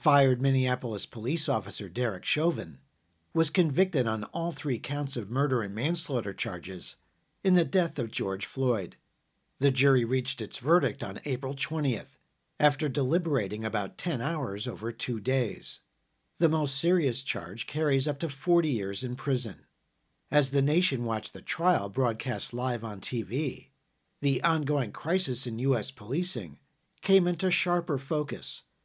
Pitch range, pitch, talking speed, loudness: 115-155 Hz, 135 Hz, 145 wpm, -29 LUFS